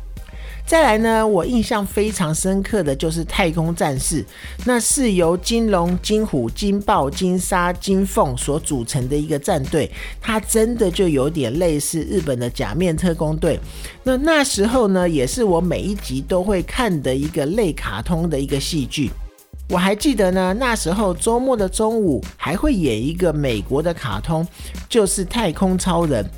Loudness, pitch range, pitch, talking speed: -19 LUFS, 145-210 Hz, 180 Hz, 245 characters per minute